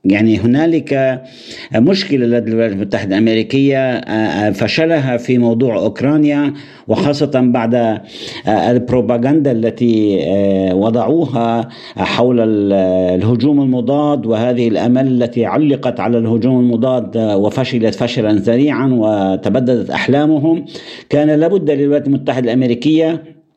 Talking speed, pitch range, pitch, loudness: 90 wpm, 115-140 Hz, 125 Hz, -14 LUFS